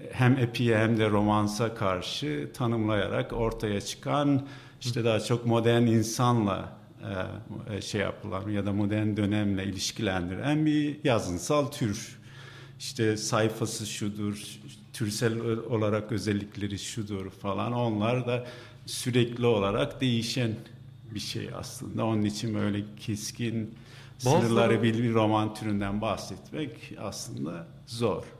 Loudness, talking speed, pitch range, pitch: -29 LUFS, 110 wpm, 105-120 Hz, 115 Hz